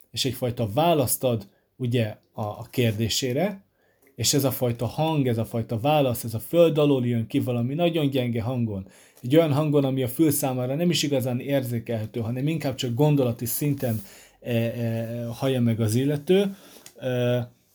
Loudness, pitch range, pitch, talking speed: -24 LUFS, 115-145 Hz, 125 Hz, 170 wpm